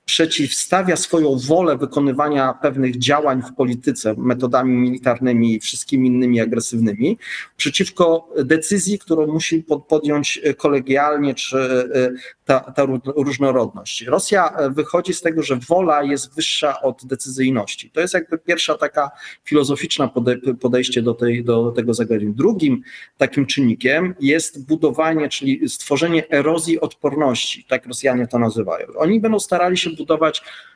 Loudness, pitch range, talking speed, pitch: -18 LUFS, 130-160 Hz, 125 wpm, 145 Hz